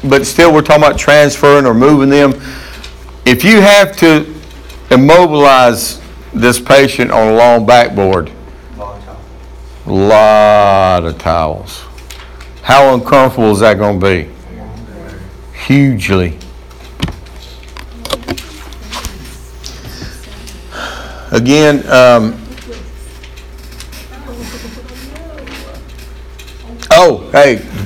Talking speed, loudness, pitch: 80 wpm, -8 LUFS, 95 Hz